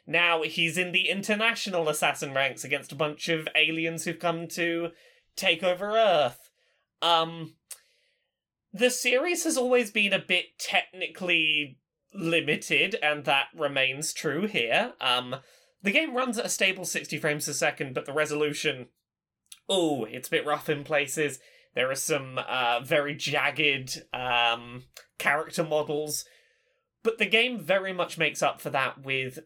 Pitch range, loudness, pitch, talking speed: 150-185 Hz, -26 LUFS, 160 Hz, 150 wpm